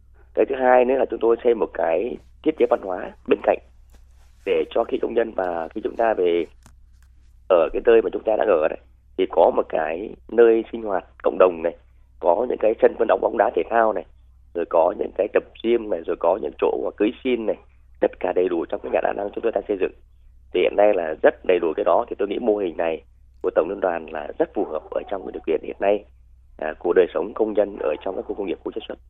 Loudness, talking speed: -22 LUFS, 265 wpm